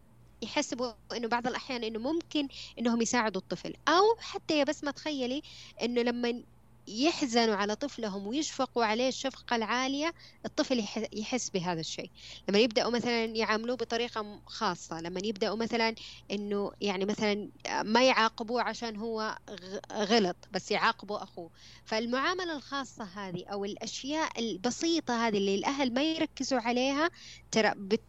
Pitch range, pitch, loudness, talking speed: 215-265 Hz, 235 Hz, -31 LUFS, 130 wpm